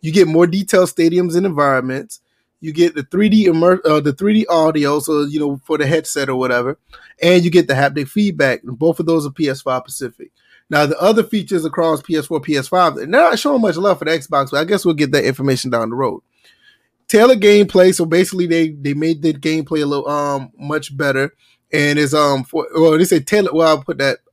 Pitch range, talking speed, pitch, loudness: 145-180 Hz, 225 wpm, 160 Hz, -15 LUFS